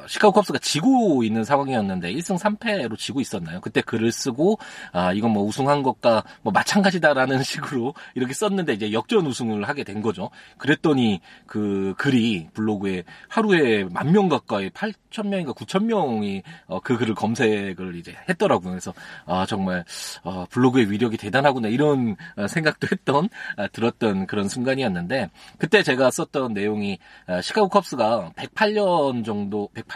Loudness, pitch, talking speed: -22 LUFS, 130 Hz, 325 characters per minute